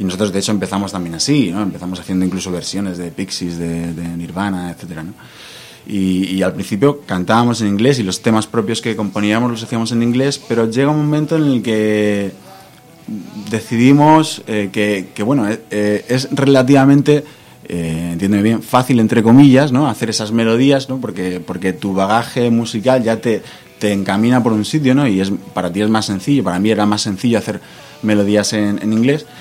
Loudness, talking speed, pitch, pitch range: -15 LUFS, 190 wpm, 110 Hz, 95-125 Hz